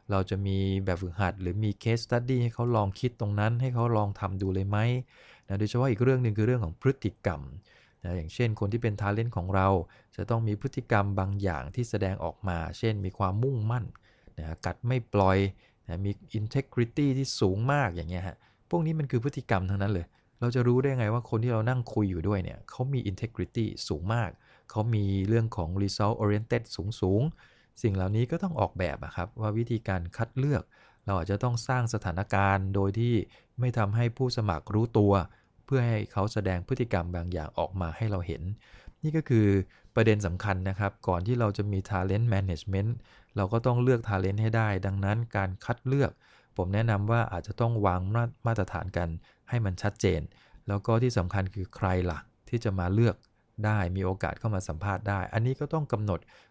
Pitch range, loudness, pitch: 95-120 Hz, -29 LUFS, 105 Hz